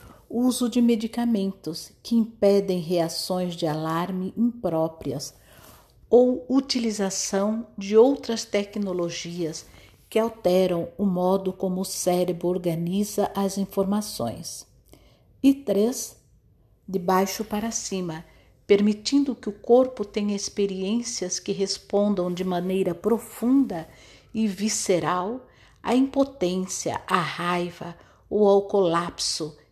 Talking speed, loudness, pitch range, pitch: 100 wpm, -24 LUFS, 180-225 Hz, 195 Hz